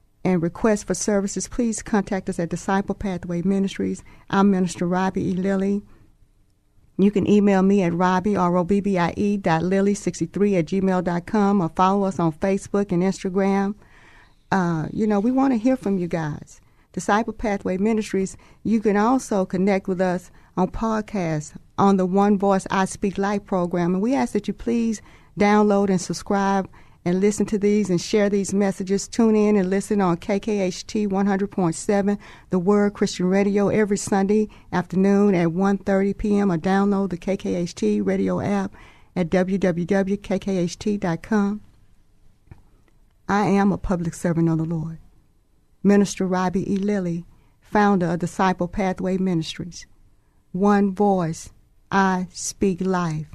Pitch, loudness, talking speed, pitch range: 195 Hz, -22 LUFS, 140 wpm, 175-205 Hz